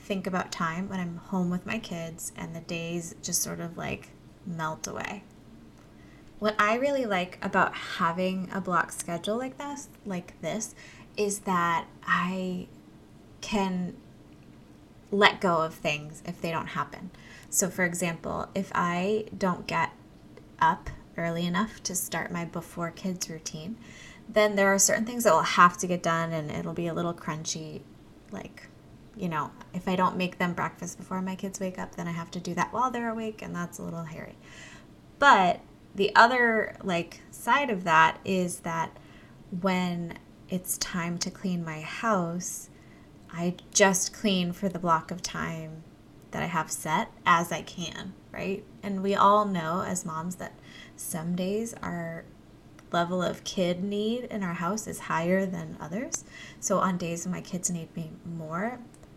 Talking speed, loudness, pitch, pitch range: 170 wpm, -28 LUFS, 180 Hz, 170-195 Hz